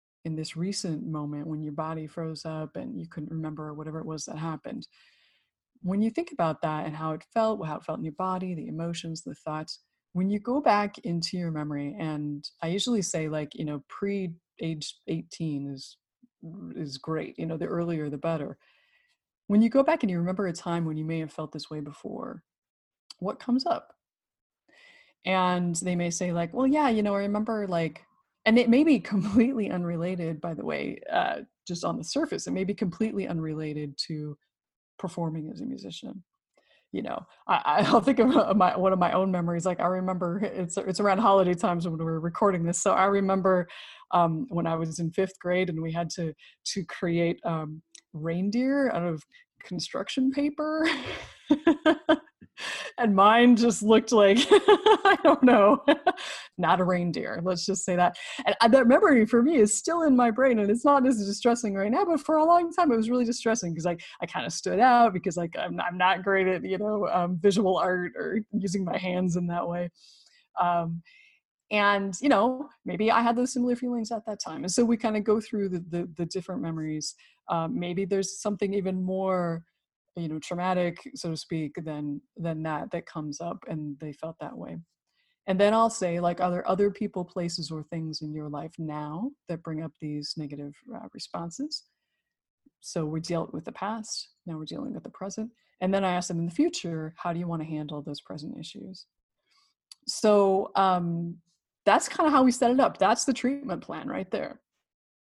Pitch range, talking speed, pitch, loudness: 165-225 Hz, 200 wpm, 185 Hz, -27 LUFS